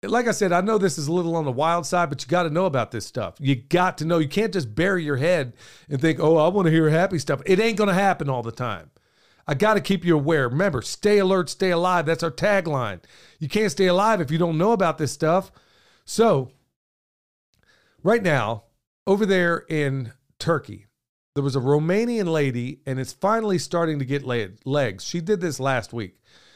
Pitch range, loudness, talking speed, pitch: 135-185 Hz, -22 LUFS, 220 wpm, 160 Hz